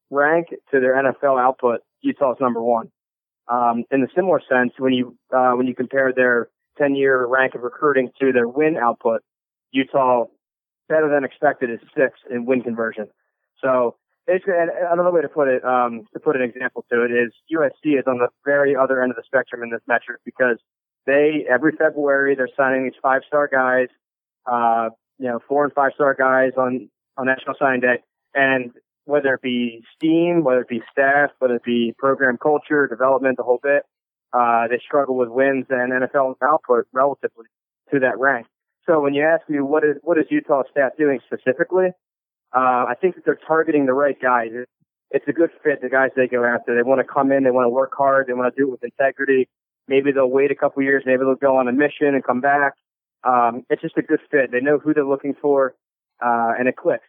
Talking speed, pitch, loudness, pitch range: 205 wpm, 130 Hz, -19 LUFS, 125-145 Hz